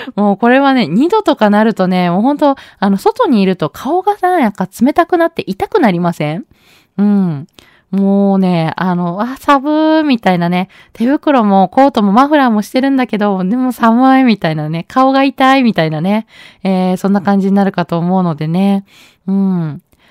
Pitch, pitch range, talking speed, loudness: 205 Hz, 185-265 Hz, 345 characters per minute, -12 LUFS